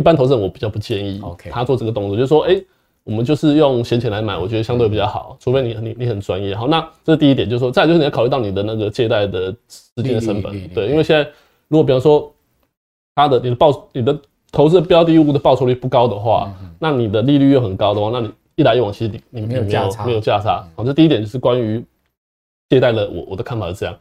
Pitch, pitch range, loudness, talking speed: 120 Hz, 105-145 Hz, -16 LUFS, 380 characters per minute